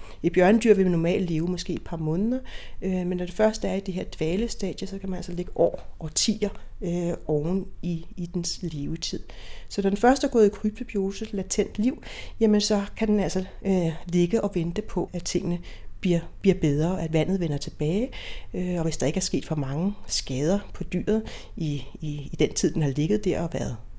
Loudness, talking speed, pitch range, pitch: -26 LUFS, 215 wpm, 165-200 Hz, 180 Hz